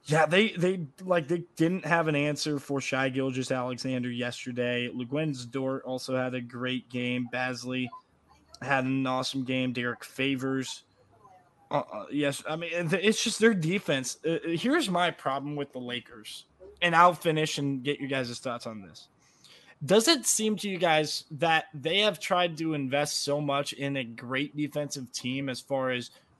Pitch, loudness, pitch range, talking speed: 140 Hz, -28 LUFS, 130-165 Hz, 170 wpm